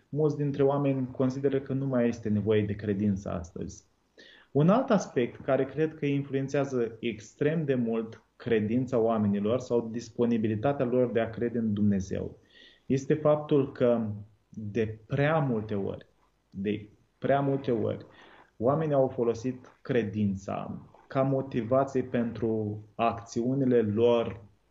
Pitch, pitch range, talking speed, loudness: 120 Hz, 110-135 Hz, 125 wpm, -29 LUFS